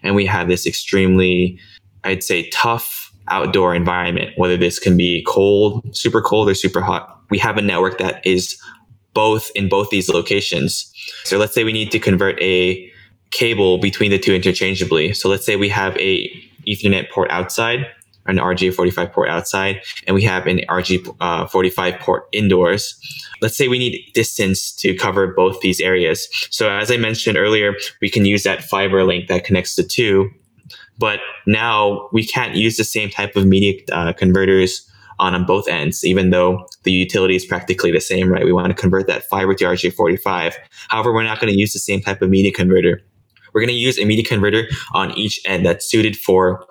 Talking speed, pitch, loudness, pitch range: 200 wpm, 95 Hz, -16 LUFS, 95-105 Hz